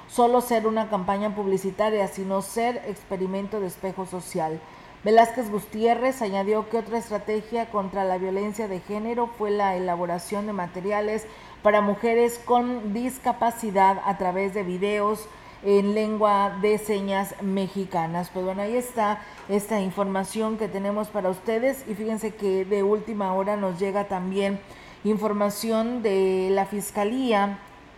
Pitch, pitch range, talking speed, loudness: 205 Hz, 195-220 Hz, 135 wpm, -25 LUFS